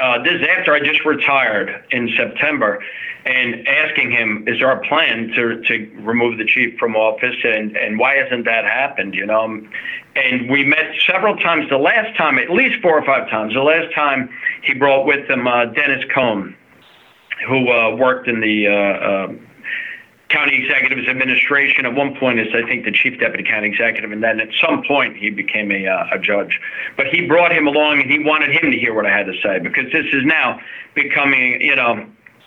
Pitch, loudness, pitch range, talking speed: 125 Hz, -15 LUFS, 110-145 Hz, 200 wpm